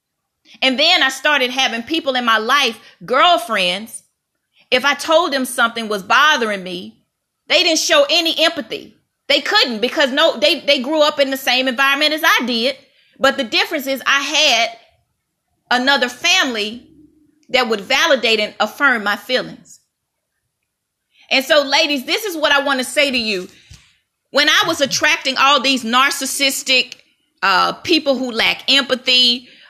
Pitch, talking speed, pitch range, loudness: 275 Hz, 155 wpm, 250-300 Hz, -15 LUFS